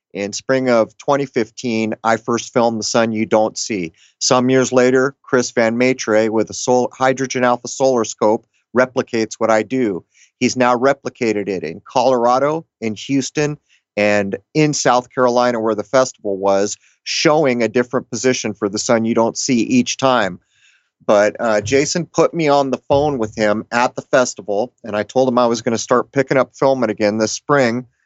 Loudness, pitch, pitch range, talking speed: -17 LUFS, 125 Hz, 110-130 Hz, 180 wpm